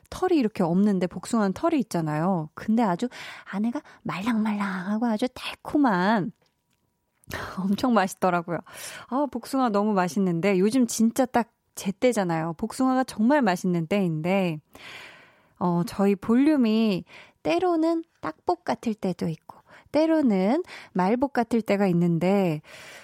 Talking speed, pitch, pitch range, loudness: 275 characters per minute, 215 Hz, 185-255 Hz, -25 LUFS